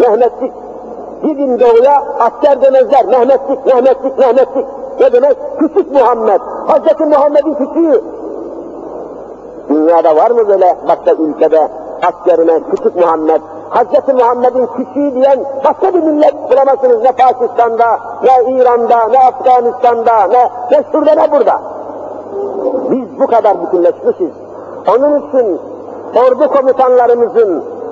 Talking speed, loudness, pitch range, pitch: 110 wpm, -10 LUFS, 240-305 Hz, 260 Hz